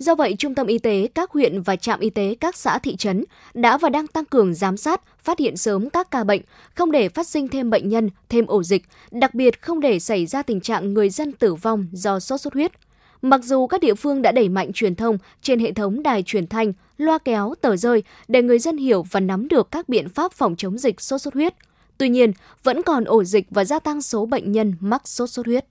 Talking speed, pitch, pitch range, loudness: 250 wpm, 235 Hz, 210-285 Hz, -20 LUFS